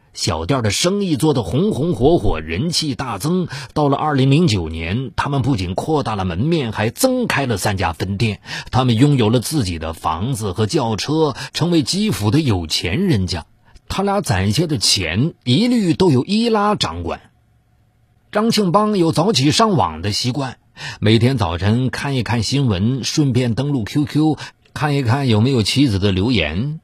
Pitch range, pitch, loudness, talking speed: 110-155 Hz, 130 Hz, -17 LUFS, 250 characters per minute